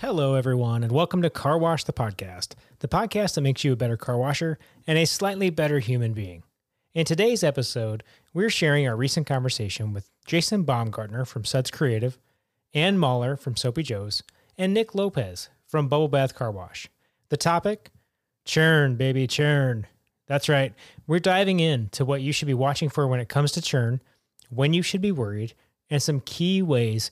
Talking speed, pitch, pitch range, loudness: 180 wpm, 140 Hz, 120-160 Hz, -24 LUFS